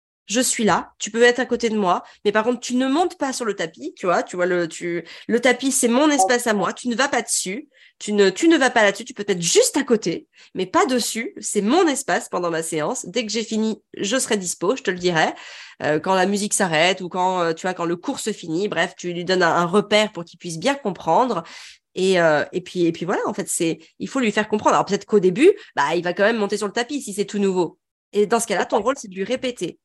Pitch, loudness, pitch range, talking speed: 205 Hz, -20 LUFS, 180-245 Hz, 280 wpm